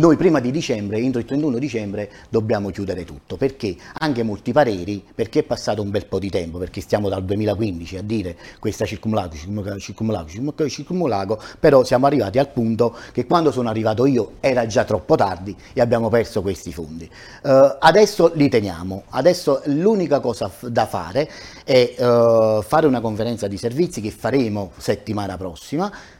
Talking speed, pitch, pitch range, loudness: 165 wpm, 115 Hz, 100-135 Hz, -20 LUFS